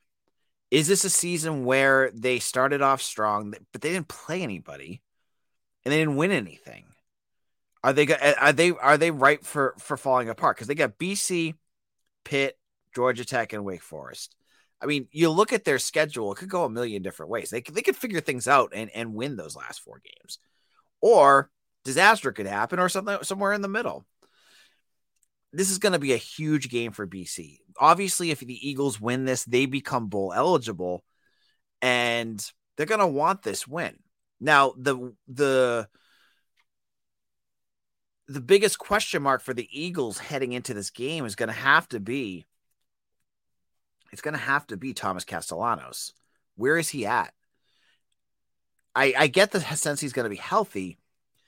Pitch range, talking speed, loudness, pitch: 125-170 Hz, 170 wpm, -24 LUFS, 140 Hz